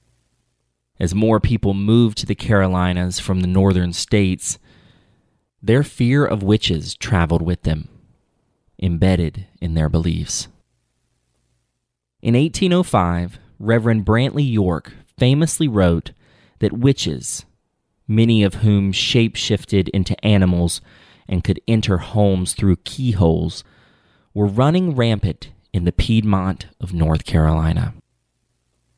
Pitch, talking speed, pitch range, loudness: 100 Hz, 110 wpm, 85-115 Hz, -18 LUFS